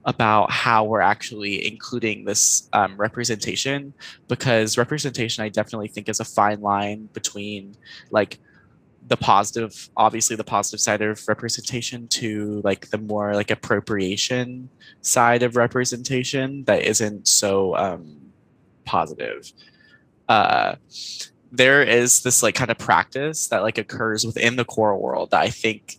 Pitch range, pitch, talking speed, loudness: 105-120 Hz, 110 Hz, 135 wpm, -20 LUFS